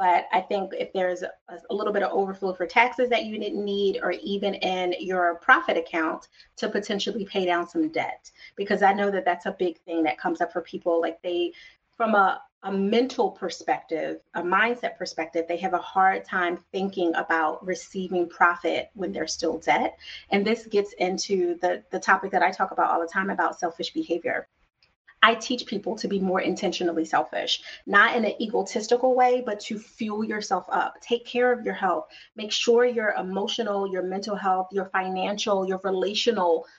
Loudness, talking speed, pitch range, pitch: -25 LUFS, 190 wpm, 175-210 Hz, 190 Hz